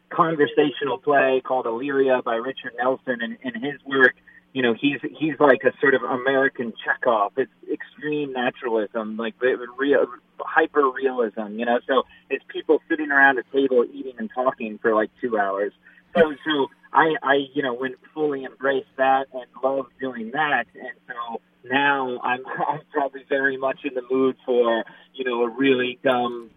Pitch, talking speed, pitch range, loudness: 130 Hz, 165 wpm, 120-140 Hz, -22 LUFS